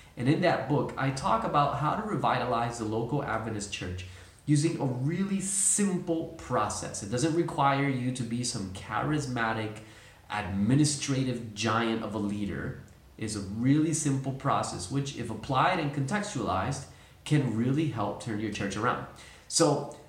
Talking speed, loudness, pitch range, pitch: 150 wpm, -29 LUFS, 110-145 Hz, 125 Hz